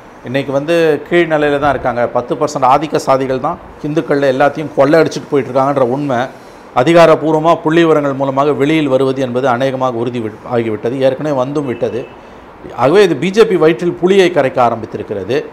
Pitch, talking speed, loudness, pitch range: 145 Hz, 140 wpm, -13 LUFS, 130-160 Hz